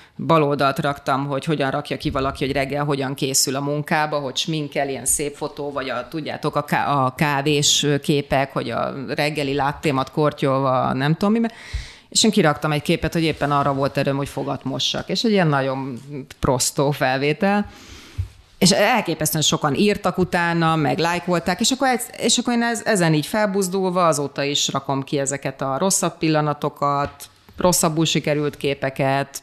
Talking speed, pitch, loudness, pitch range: 155 wpm, 150 Hz, -20 LUFS, 140-170 Hz